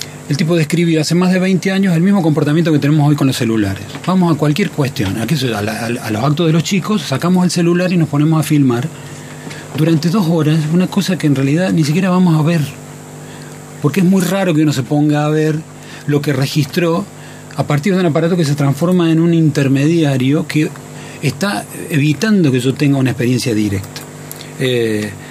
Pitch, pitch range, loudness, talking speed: 150 Hz, 140-170 Hz, -14 LUFS, 200 wpm